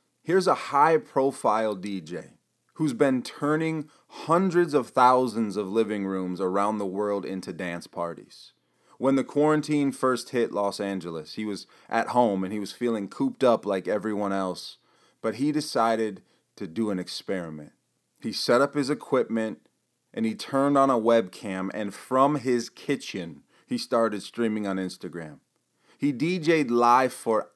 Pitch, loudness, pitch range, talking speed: 115 Hz, -26 LUFS, 100-140 Hz, 155 wpm